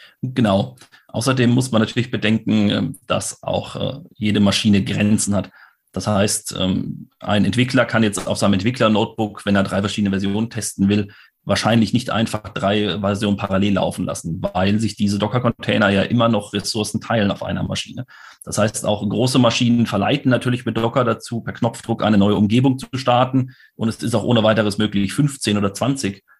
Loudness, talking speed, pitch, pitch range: -19 LUFS, 170 wpm, 105 Hz, 100-115 Hz